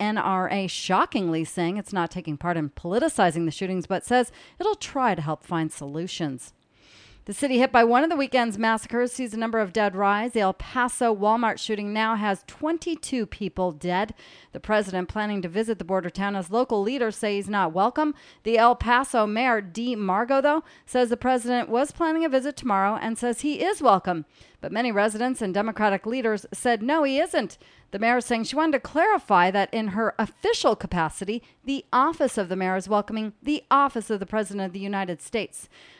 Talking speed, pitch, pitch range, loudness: 195 wpm, 220 Hz, 195-250 Hz, -24 LUFS